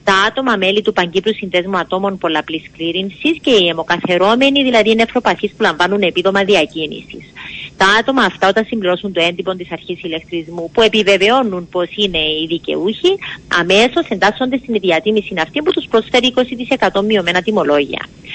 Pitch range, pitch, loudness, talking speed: 175-225 Hz, 195 Hz, -14 LUFS, 150 wpm